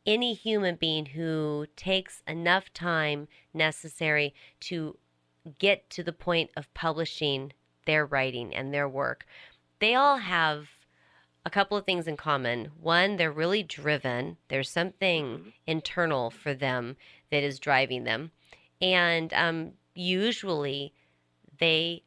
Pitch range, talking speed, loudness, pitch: 140-175 Hz, 125 wpm, -28 LUFS, 160 Hz